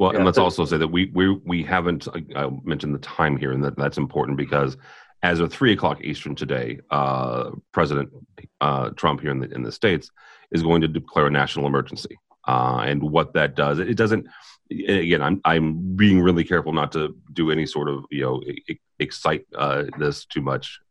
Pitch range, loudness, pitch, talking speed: 70-85 Hz, -22 LUFS, 75 Hz, 200 wpm